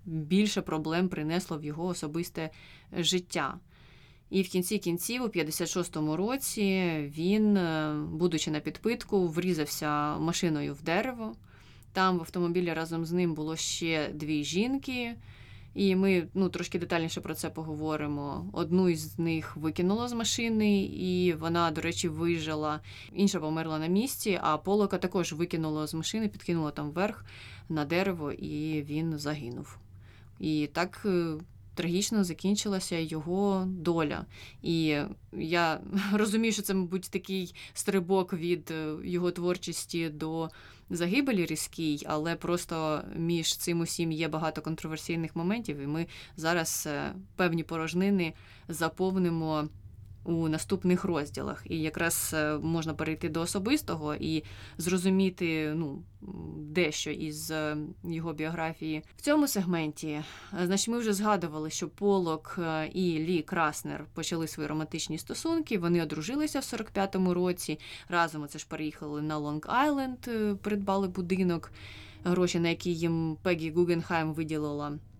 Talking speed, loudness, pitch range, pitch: 125 wpm, -31 LUFS, 155-185 Hz, 165 Hz